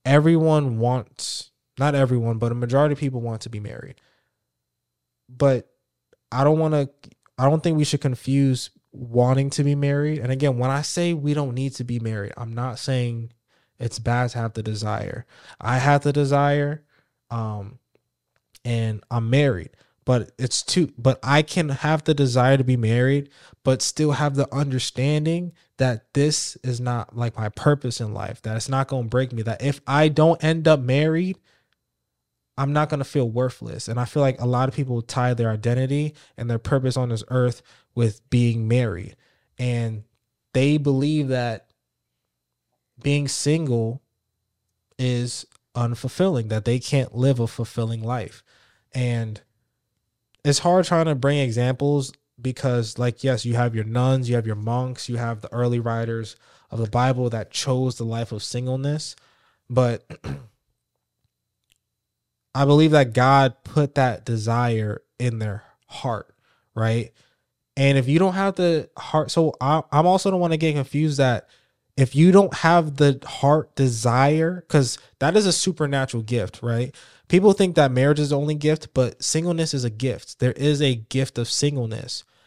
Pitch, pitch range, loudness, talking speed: 130 Hz, 115-145 Hz, -22 LUFS, 165 wpm